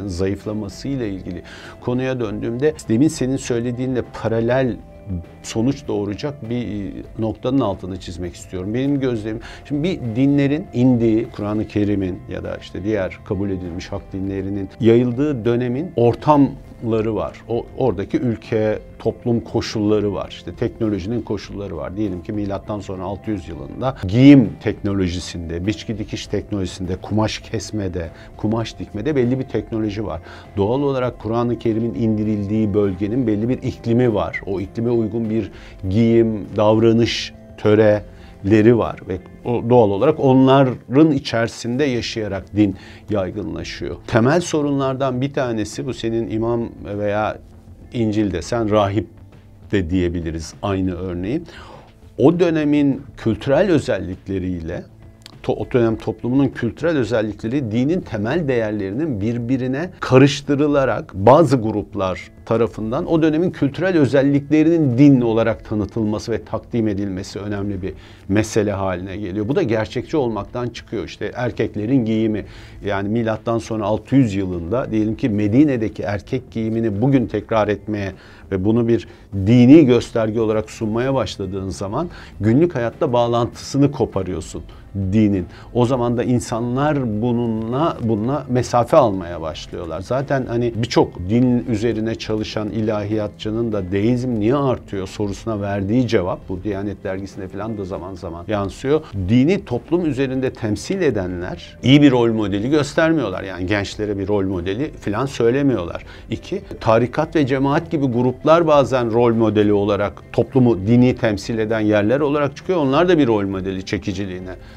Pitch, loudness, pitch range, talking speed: 110 Hz, -19 LUFS, 100-125 Hz, 130 wpm